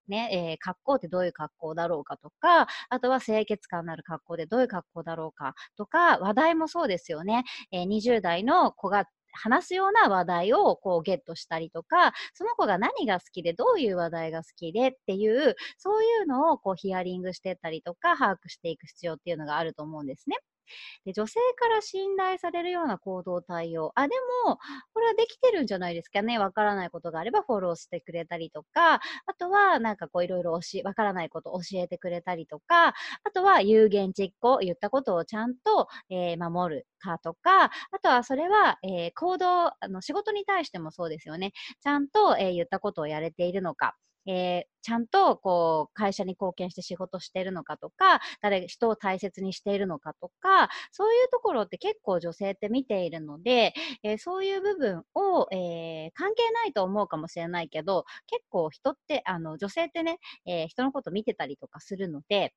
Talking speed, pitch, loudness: 395 characters per minute, 200 Hz, -27 LUFS